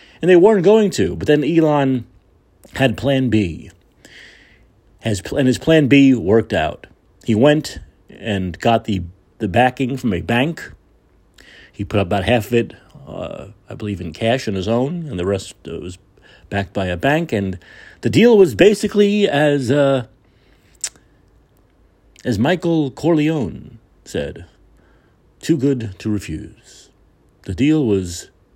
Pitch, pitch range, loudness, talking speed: 120 Hz, 100-145 Hz, -17 LUFS, 150 wpm